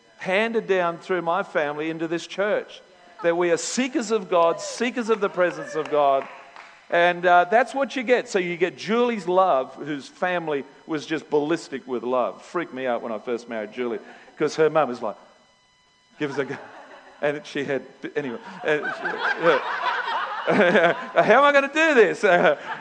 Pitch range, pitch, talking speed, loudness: 145-220 Hz, 170 Hz, 180 wpm, -23 LUFS